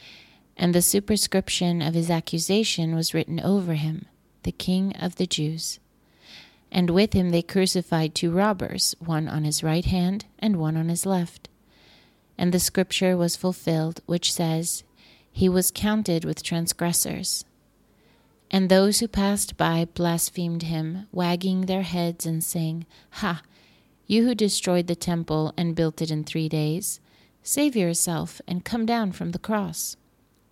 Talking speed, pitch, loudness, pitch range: 150 wpm, 175 Hz, -24 LUFS, 165-190 Hz